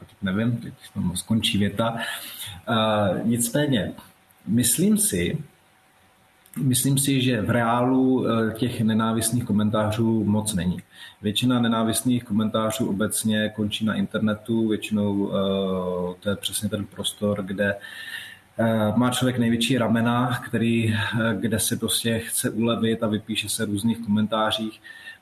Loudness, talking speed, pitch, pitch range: -23 LUFS, 130 wpm, 110 Hz, 105-120 Hz